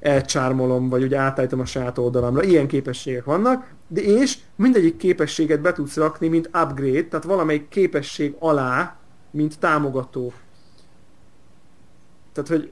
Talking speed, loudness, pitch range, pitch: 125 wpm, -21 LUFS, 130-165 Hz, 150 Hz